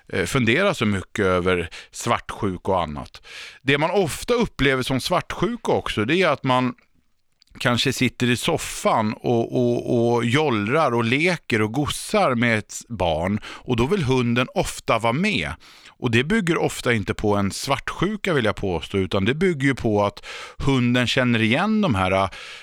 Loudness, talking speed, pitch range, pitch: -21 LUFS, 160 wpm, 110-140 Hz, 125 Hz